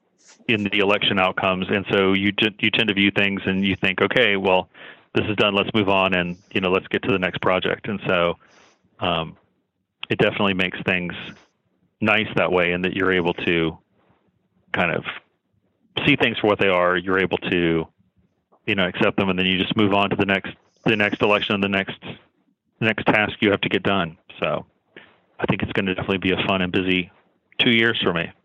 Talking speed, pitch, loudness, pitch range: 210 wpm, 95 Hz, -20 LUFS, 90-100 Hz